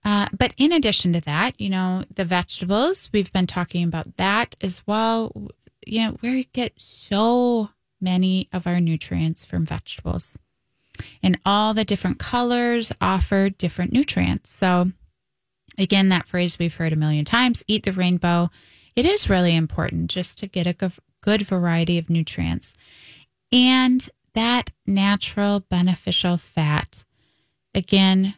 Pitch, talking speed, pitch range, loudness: 190 Hz, 135 wpm, 175-215 Hz, -21 LUFS